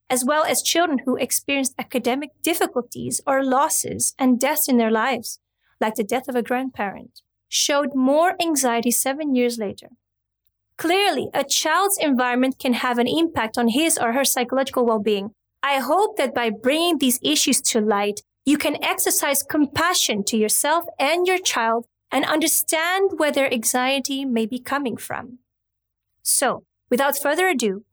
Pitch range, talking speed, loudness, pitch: 235-300 Hz, 155 wpm, -20 LUFS, 260 Hz